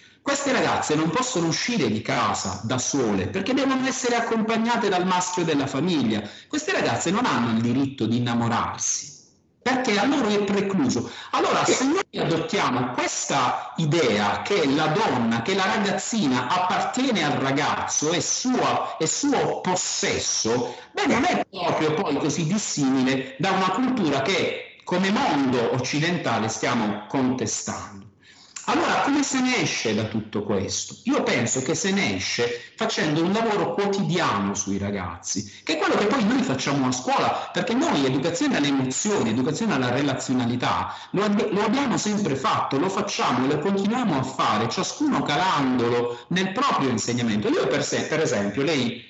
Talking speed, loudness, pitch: 155 wpm, -23 LUFS, 165 Hz